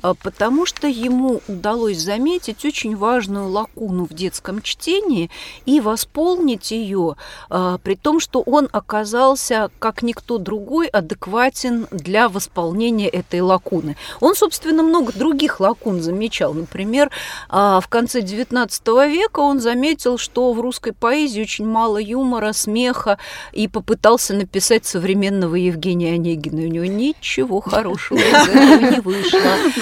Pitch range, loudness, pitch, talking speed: 195-265 Hz, -17 LUFS, 225 Hz, 125 wpm